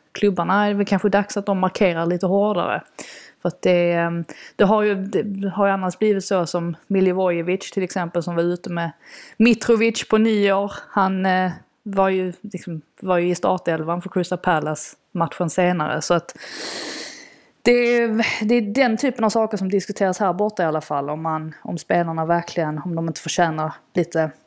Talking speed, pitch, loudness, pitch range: 185 wpm, 185 Hz, -21 LUFS, 170-205 Hz